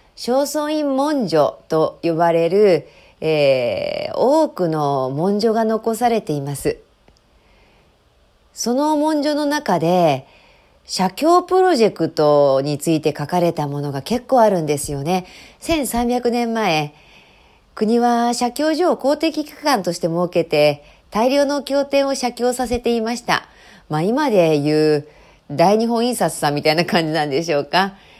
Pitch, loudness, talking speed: 215 Hz, -18 LUFS, 250 characters per minute